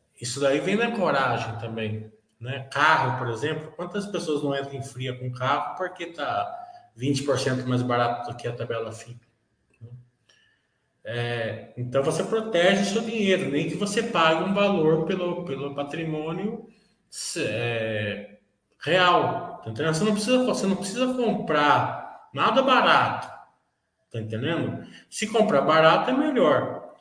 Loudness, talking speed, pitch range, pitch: -24 LUFS, 140 wpm, 120-190 Hz, 145 Hz